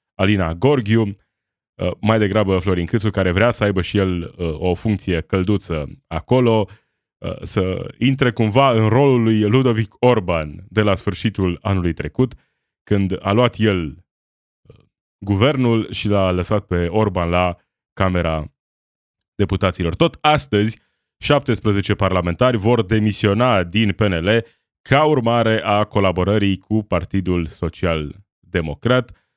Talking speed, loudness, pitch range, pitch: 120 wpm, -18 LUFS, 90-115 Hz, 100 Hz